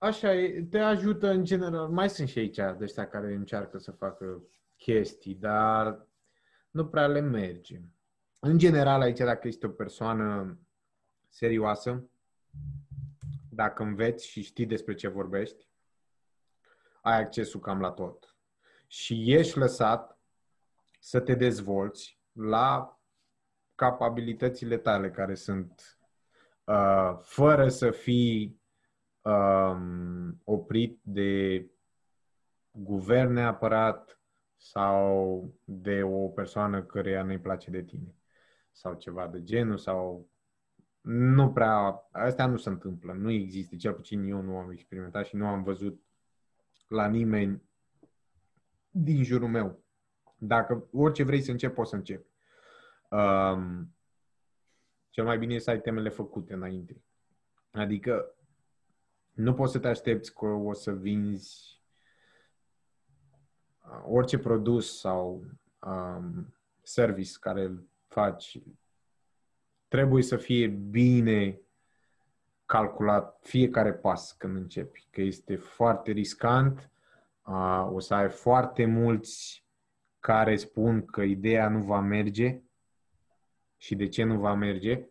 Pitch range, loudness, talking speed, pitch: 95-120 Hz, -29 LUFS, 115 wpm, 110 Hz